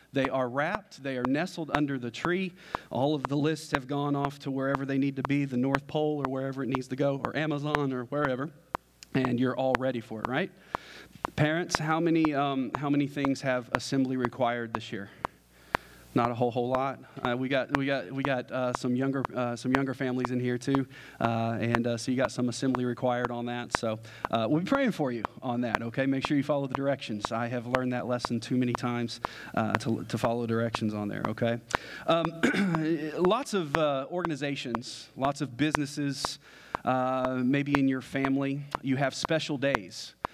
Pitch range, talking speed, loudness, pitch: 120-145 Hz, 200 wpm, -30 LUFS, 130 Hz